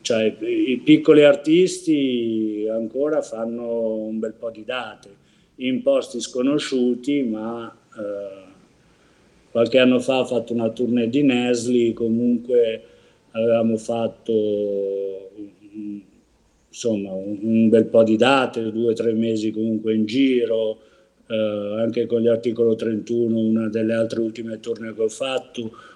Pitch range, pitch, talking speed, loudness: 110-125 Hz, 115 Hz, 125 wpm, -21 LUFS